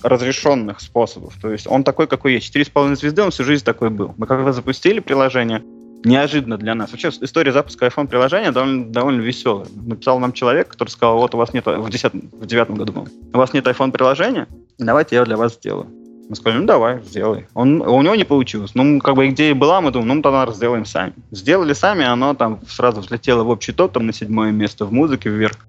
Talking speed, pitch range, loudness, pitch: 215 wpm, 115-135 Hz, -17 LUFS, 120 Hz